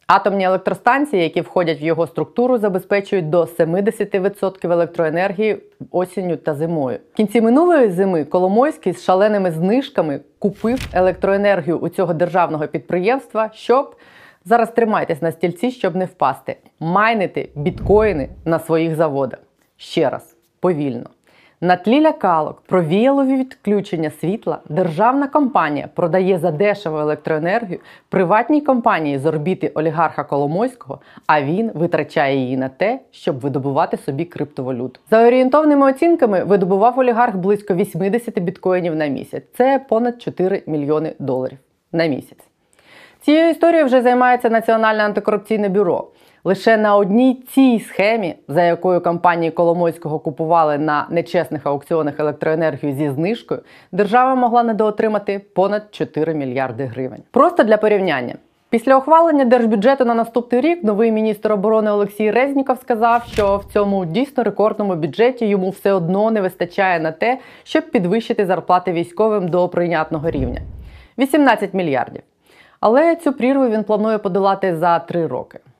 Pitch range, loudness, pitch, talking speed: 165-230 Hz, -17 LUFS, 195 Hz, 130 wpm